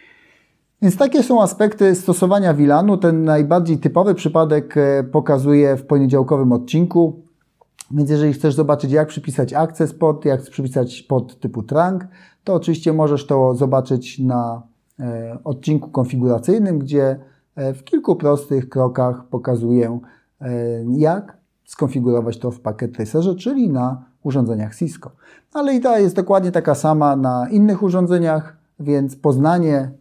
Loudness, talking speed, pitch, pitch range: -17 LUFS, 125 wpm, 150 Hz, 130-170 Hz